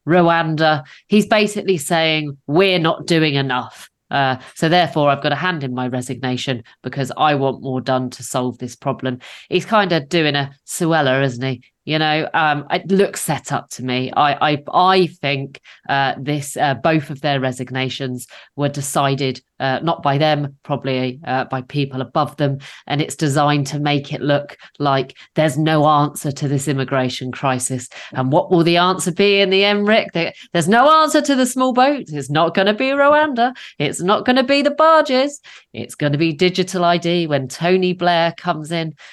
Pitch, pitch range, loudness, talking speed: 150 Hz, 135-180 Hz, -17 LUFS, 190 wpm